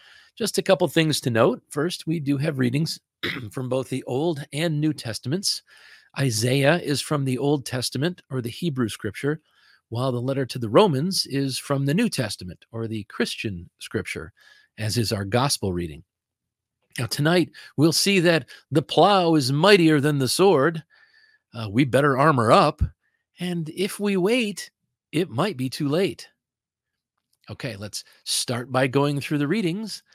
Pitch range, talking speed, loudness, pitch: 125-170 Hz, 165 wpm, -23 LUFS, 140 Hz